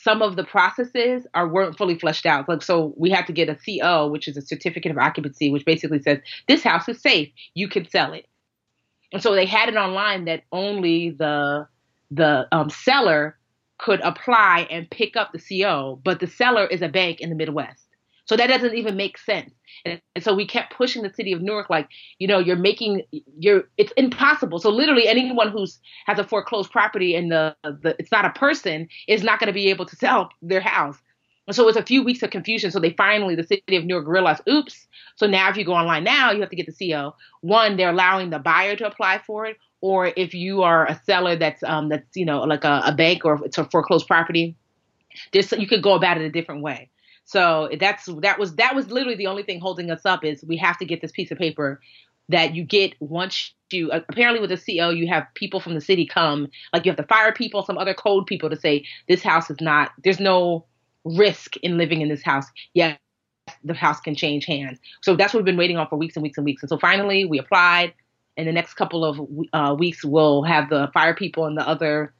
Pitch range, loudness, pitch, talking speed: 155-200 Hz, -20 LUFS, 175 Hz, 230 wpm